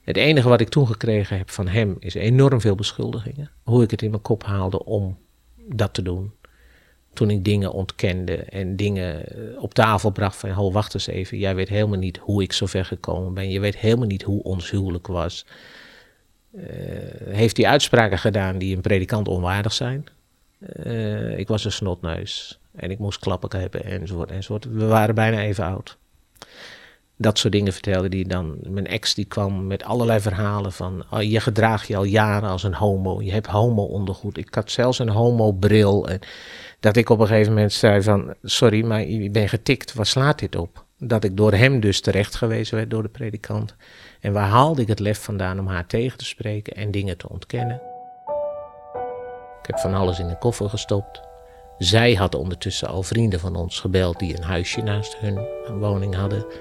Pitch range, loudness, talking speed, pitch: 95-115 Hz, -21 LUFS, 195 wpm, 105 Hz